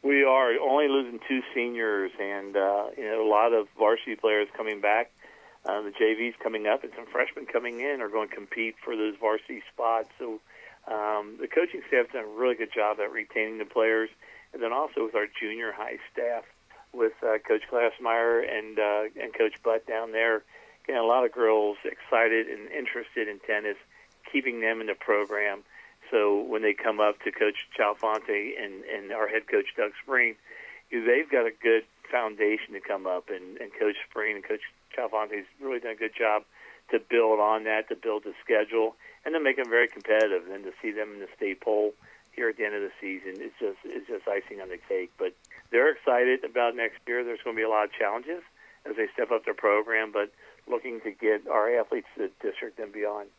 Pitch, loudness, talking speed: 120 Hz, -28 LUFS, 210 wpm